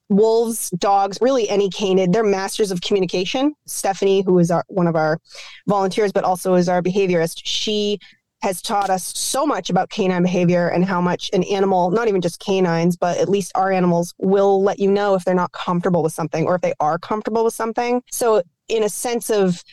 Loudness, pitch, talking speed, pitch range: -19 LUFS, 195 Hz, 205 wpm, 180-210 Hz